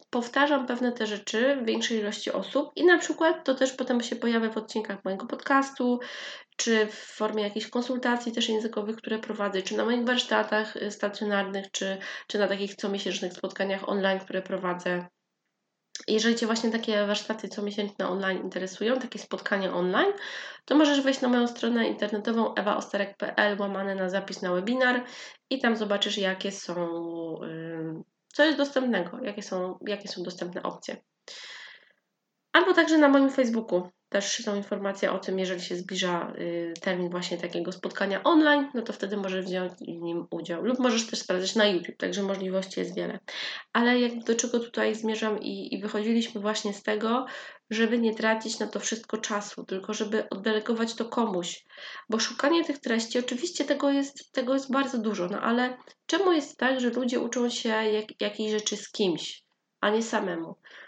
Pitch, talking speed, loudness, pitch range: 220 Hz, 170 wpm, -28 LUFS, 195-245 Hz